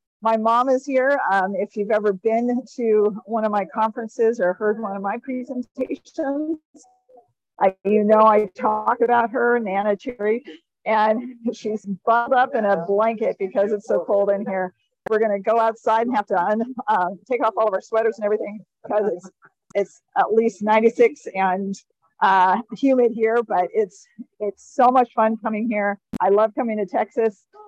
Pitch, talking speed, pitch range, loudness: 220 Hz, 180 wpm, 205-240 Hz, -21 LUFS